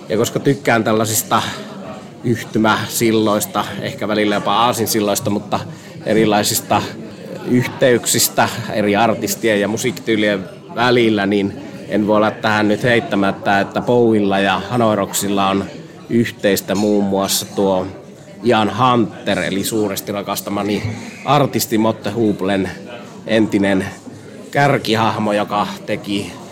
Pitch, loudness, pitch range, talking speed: 105 Hz, -17 LUFS, 100-115 Hz, 100 wpm